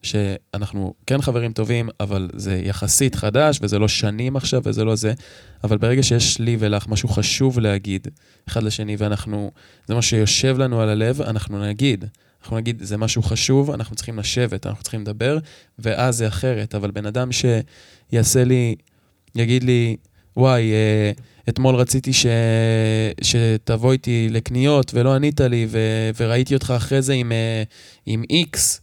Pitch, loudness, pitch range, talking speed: 115 Hz, -19 LUFS, 105-125 Hz, 150 wpm